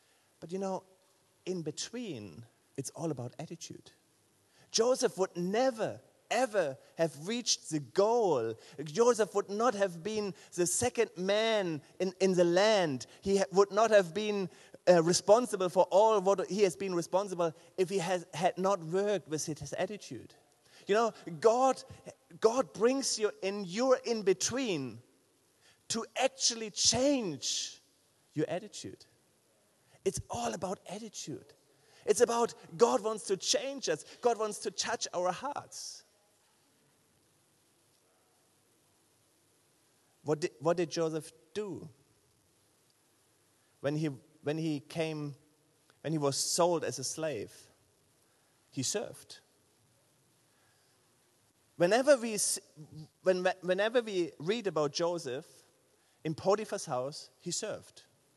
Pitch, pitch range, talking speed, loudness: 180 Hz, 150-210 Hz, 120 wpm, -32 LUFS